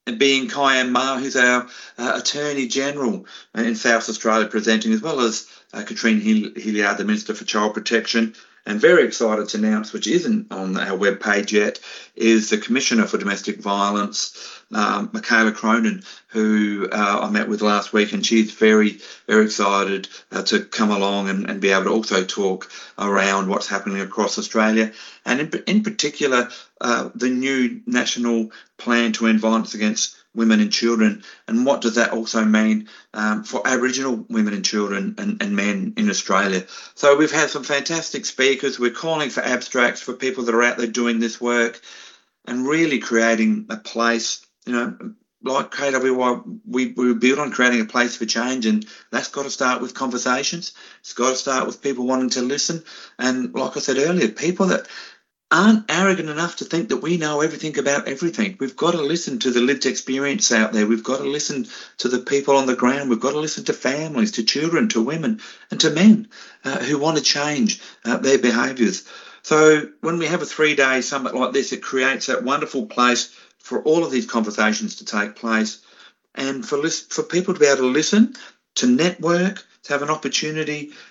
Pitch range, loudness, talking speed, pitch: 110-155 Hz, -20 LUFS, 190 wpm, 130 Hz